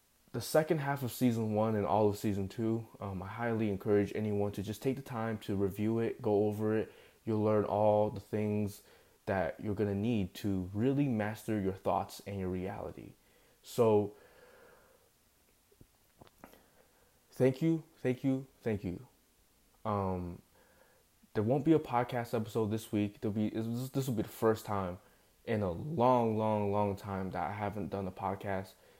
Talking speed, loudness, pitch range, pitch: 165 wpm, -34 LUFS, 100-120 Hz, 110 Hz